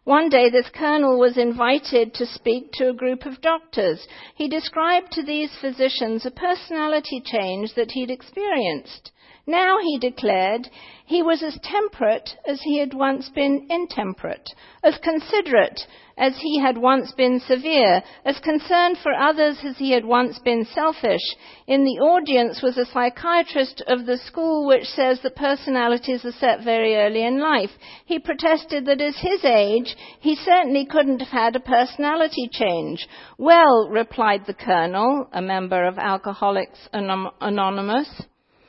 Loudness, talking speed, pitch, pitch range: -20 LUFS, 150 wpm, 265 Hz, 240-310 Hz